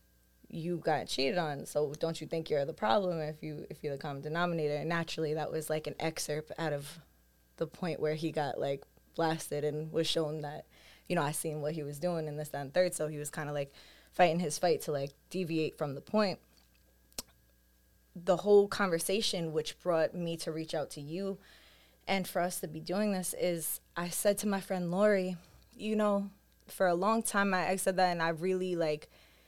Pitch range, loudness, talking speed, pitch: 150-180 Hz, -33 LUFS, 210 wpm, 160 Hz